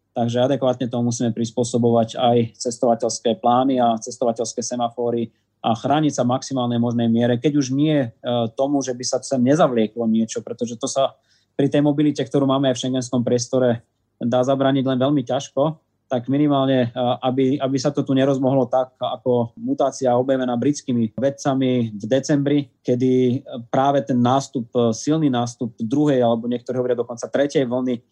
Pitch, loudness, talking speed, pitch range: 125 Hz, -20 LUFS, 160 wpm, 120-135 Hz